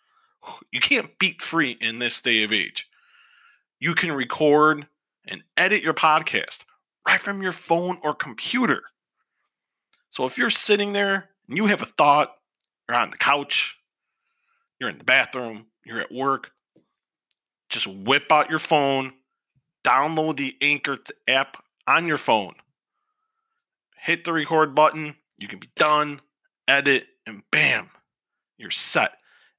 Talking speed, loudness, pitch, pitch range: 140 wpm, -21 LUFS, 155 Hz, 145-205 Hz